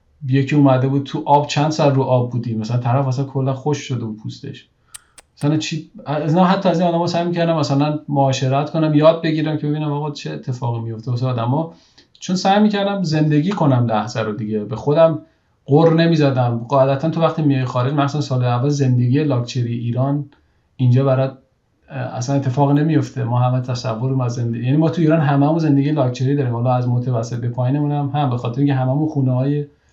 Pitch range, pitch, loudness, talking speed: 125-150 Hz, 140 Hz, -18 LUFS, 185 wpm